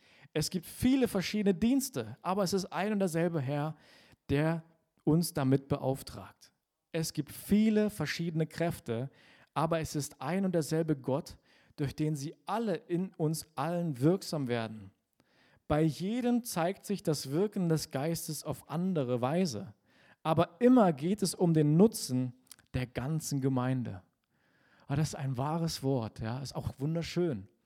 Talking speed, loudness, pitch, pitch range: 150 wpm, -32 LUFS, 155 Hz, 135-175 Hz